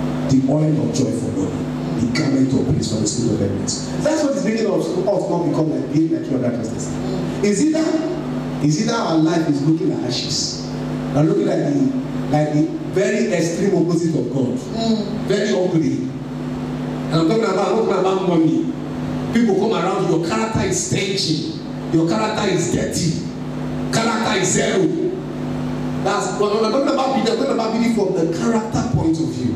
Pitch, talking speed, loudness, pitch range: 175 Hz, 225 wpm, -19 LUFS, 150-220 Hz